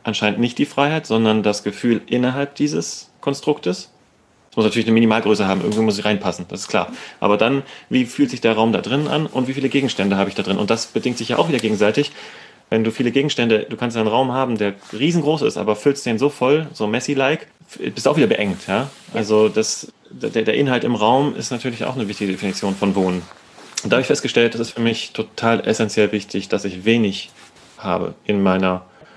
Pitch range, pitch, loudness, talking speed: 105-130 Hz, 110 Hz, -19 LUFS, 220 wpm